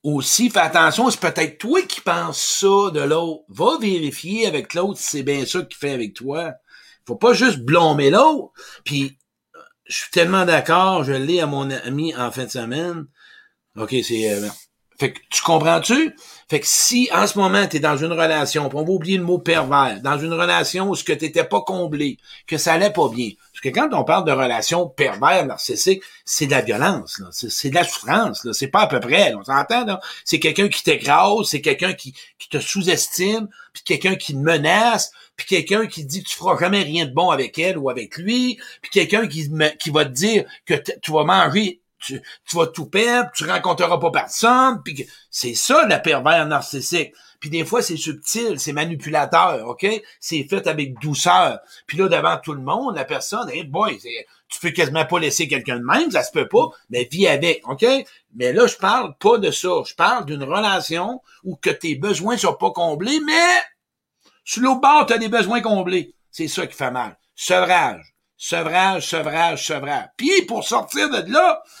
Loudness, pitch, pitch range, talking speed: -18 LUFS, 175 Hz, 150-220 Hz, 210 wpm